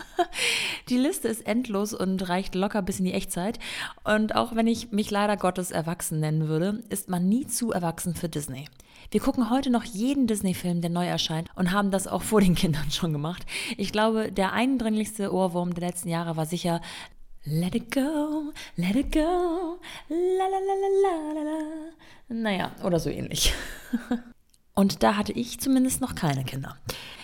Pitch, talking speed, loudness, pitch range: 205 Hz, 175 wpm, -27 LUFS, 175-250 Hz